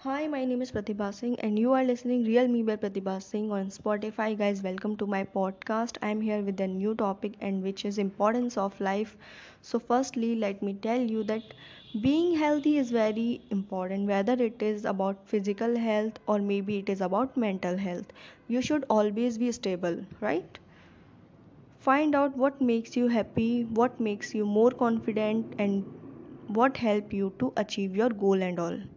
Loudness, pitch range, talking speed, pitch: -29 LUFS, 200-240 Hz, 180 wpm, 215 Hz